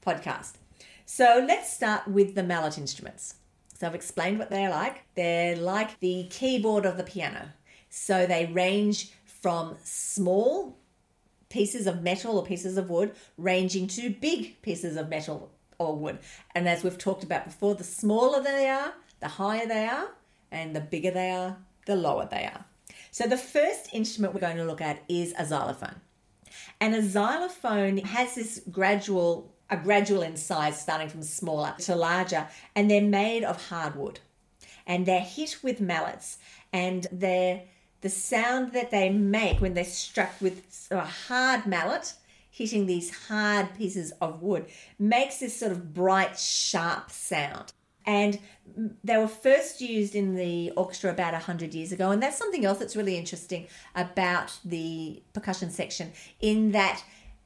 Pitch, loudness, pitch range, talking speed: 190 Hz, -28 LUFS, 175-215 Hz, 160 wpm